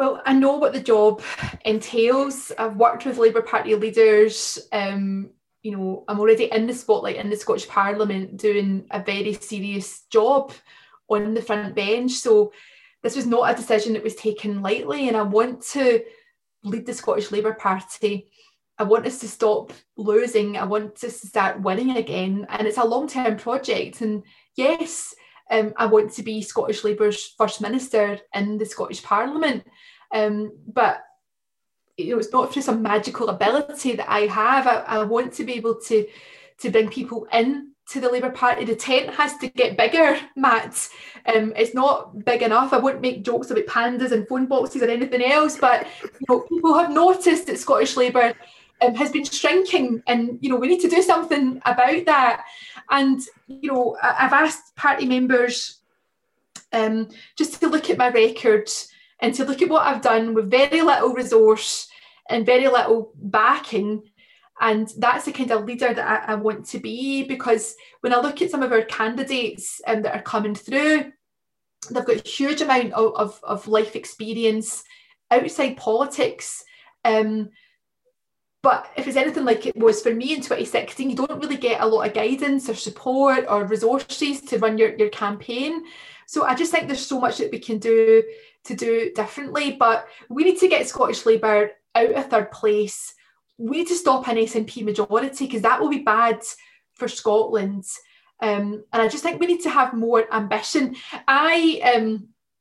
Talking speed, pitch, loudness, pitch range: 180 wpm, 240 Hz, -21 LUFS, 220-280 Hz